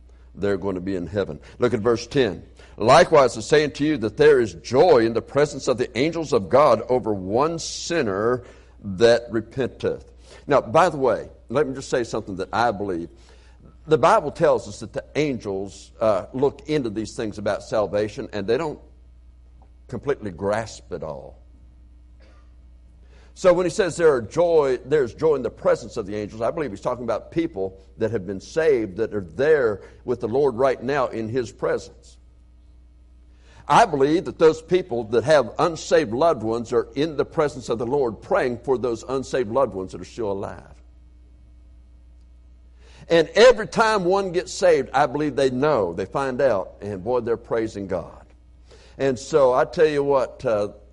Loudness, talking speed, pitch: -22 LUFS, 180 wpm, 110 Hz